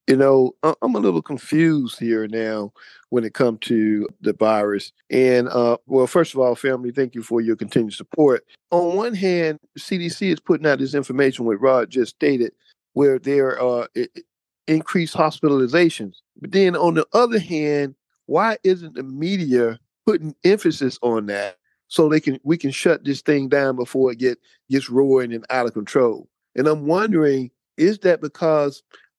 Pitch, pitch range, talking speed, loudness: 135 Hz, 120-160 Hz, 170 wpm, -20 LUFS